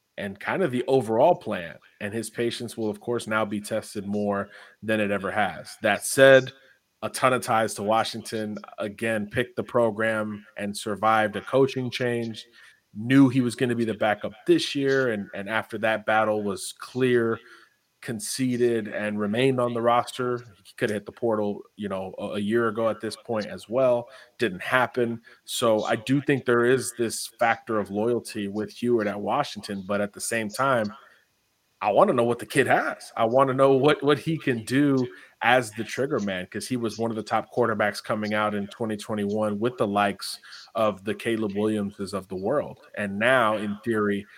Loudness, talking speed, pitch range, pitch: -25 LUFS, 195 wpm, 105-120 Hz, 110 Hz